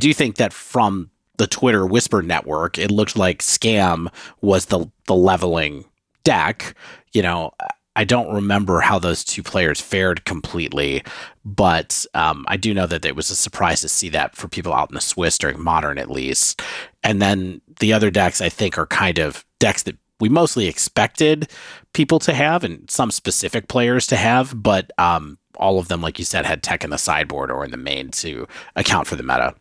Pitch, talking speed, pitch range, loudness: 95 Hz, 200 wpm, 85-110 Hz, -19 LUFS